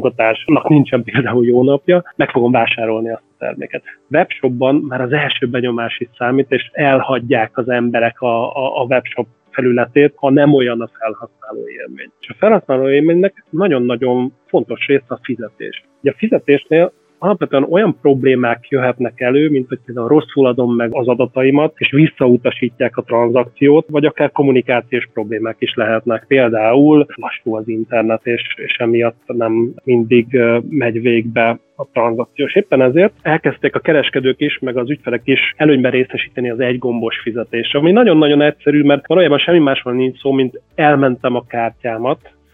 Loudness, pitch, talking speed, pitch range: -14 LUFS, 130 Hz, 155 wpm, 120-145 Hz